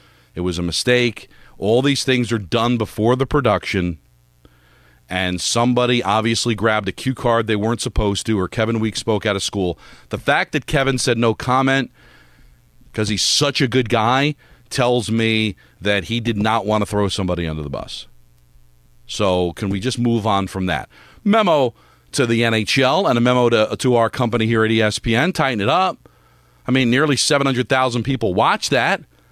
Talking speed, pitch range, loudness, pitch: 180 wpm, 95-125 Hz, -18 LUFS, 115 Hz